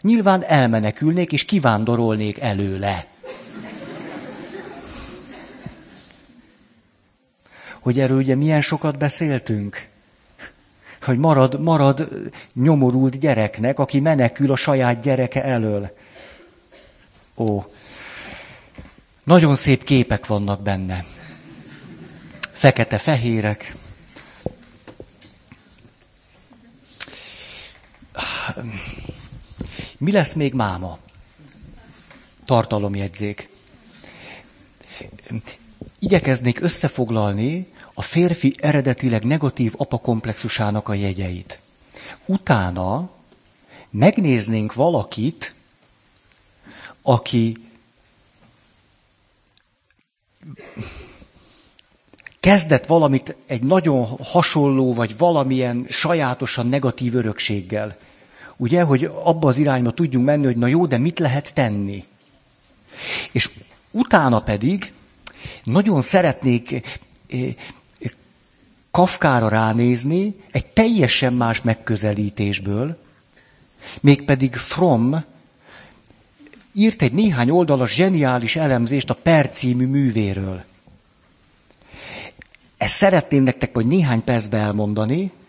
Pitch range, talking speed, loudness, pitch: 105-150 Hz, 70 wpm, -19 LUFS, 125 Hz